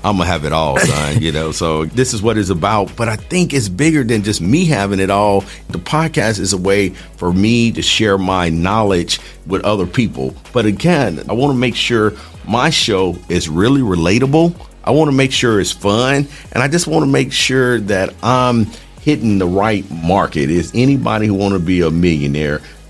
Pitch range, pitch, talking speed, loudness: 90-125 Hz, 105 Hz, 195 wpm, -14 LUFS